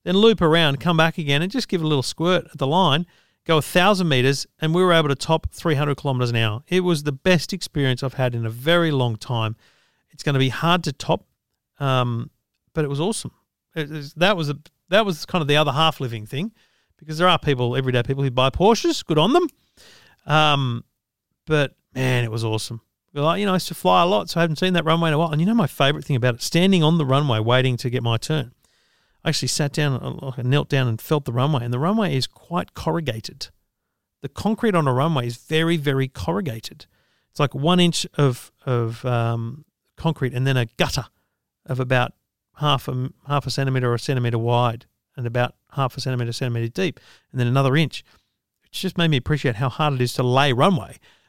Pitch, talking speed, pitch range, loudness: 140 Hz, 225 wpm, 125-165 Hz, -21 LUFS